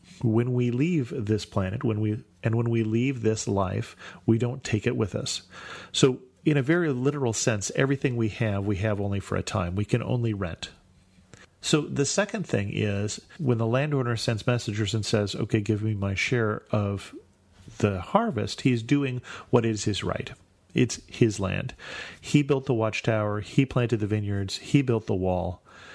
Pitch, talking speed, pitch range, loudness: 110 Hz, 185 wpm, 105-125 Hz, -27 LUFS